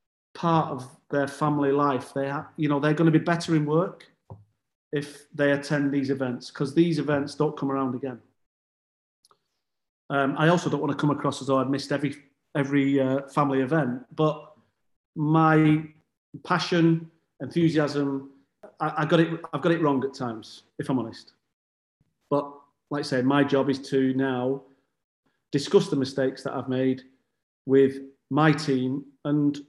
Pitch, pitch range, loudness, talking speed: 145 Hz, 135-155 Hz, -25 LUFS, 165 wpm